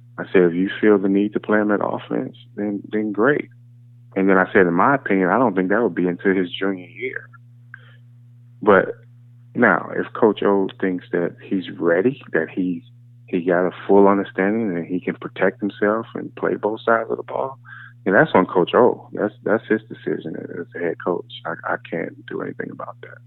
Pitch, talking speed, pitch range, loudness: 105 Hz, 205 wpm, 95-120 Hz, -20 LUFS